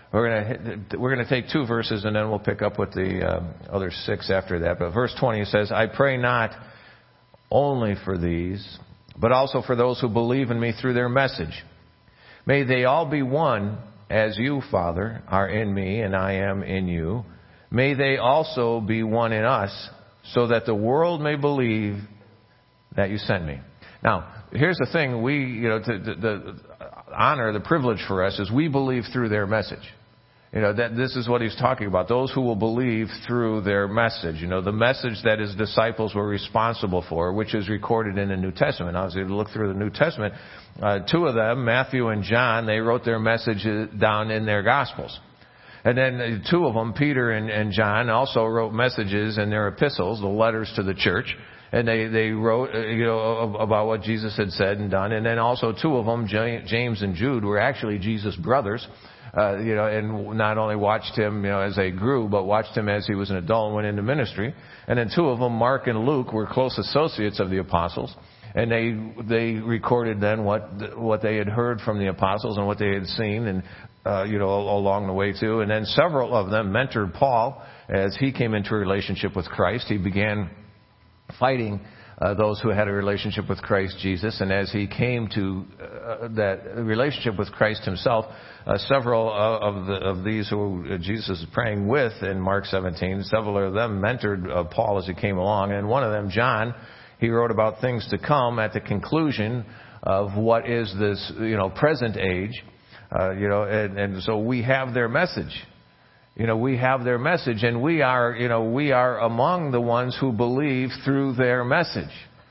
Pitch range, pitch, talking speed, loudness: 100-120 Hz, 110 Hz, 205 wpm, -24 LUFS